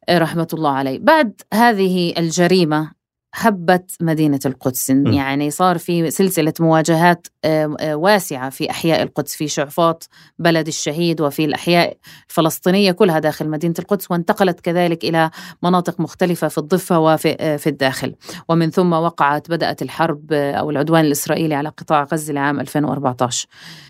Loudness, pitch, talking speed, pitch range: -17 LUFS, 160 Hz, 130 wpm, 150-175 Hz